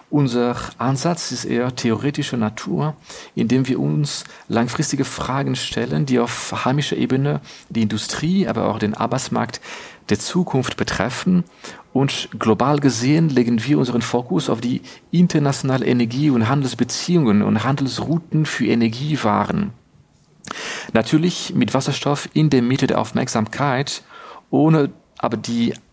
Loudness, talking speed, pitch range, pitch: -19 LUFS, 125 wpm, 120-150 Hz, 130 Hz